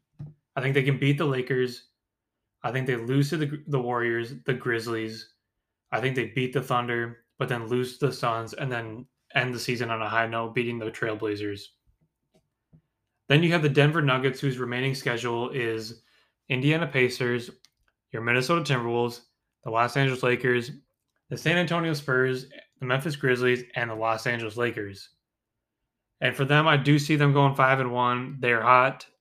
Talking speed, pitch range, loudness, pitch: 175 wpm, 115-140 Hz, -26 LUFS, 125 Hz